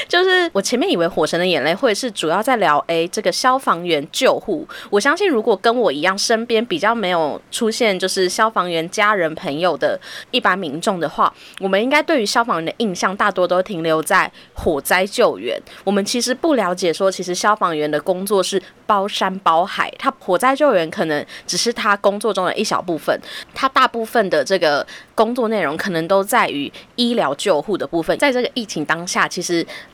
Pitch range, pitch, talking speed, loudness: 180-240 Hz, 205 Hz, 305 characters per minute, -18 LUFS